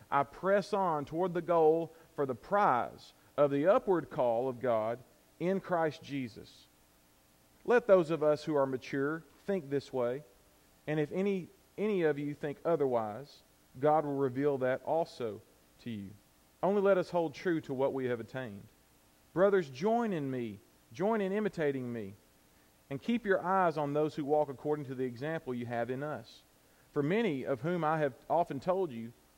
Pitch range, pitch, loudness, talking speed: 120-170 Hz, 145 Hz, -33 LUFS, 175 wpm